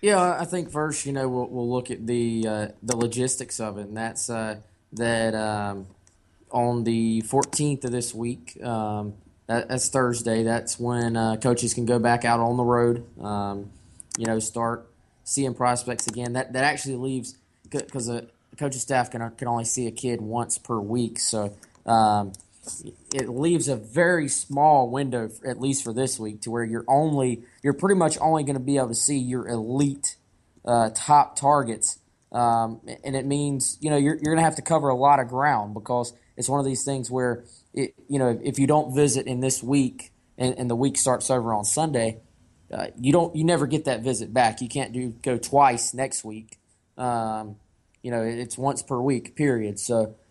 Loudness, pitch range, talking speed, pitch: -24 LUFS, 115-135 Hz, 195 wpm, 120 Hz